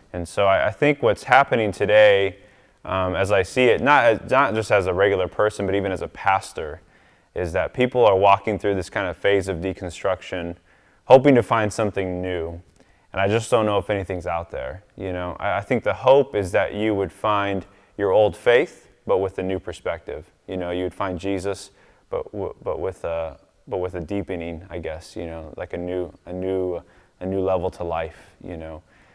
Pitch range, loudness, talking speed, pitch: 90-105 Hz, -21 LUFS, 210 wpm, 95 Hz